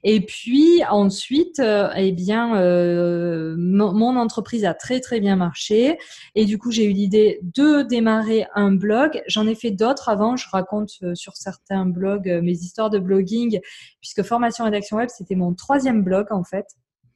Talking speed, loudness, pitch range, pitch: 170 wpm, -20 LUFS, 190-230 Hz, 210 Hz